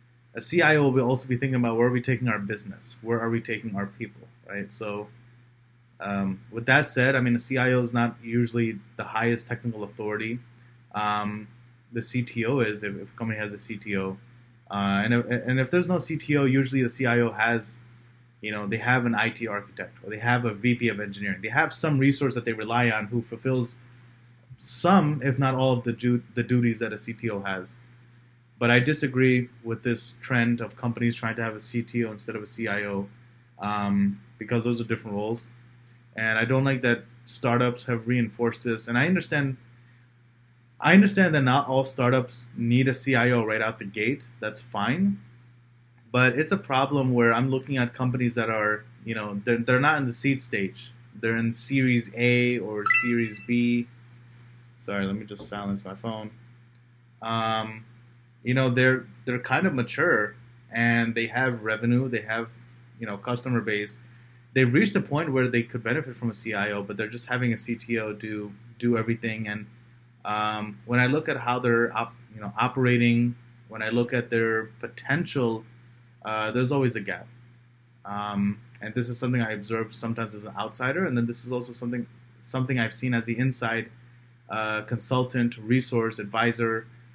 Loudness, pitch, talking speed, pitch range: -26 LUFS, 120 Hz, 185 wpm, 115-125 Hz